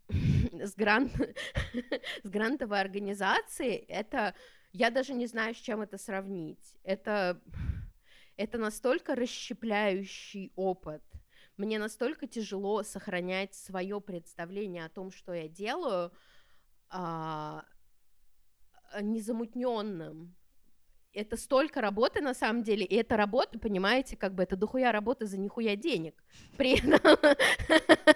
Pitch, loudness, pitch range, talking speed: 210 Hz, -31 LUFS, 190-245 Hz, 115 wpm